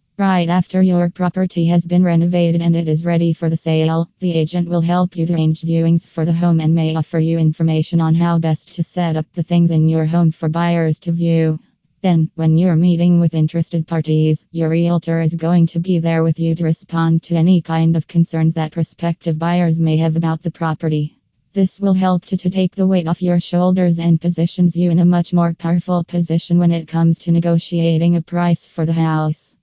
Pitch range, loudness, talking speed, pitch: 160-175 Hz, -16 LUFS, 215 wpm, 170 Hz